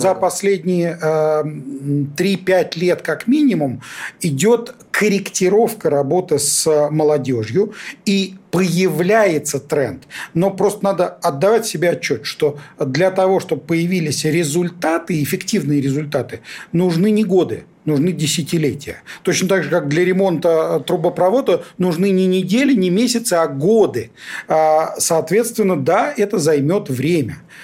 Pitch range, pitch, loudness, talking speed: 155-195 Hz, 175 Hz, -17 LUFS, 115 wpm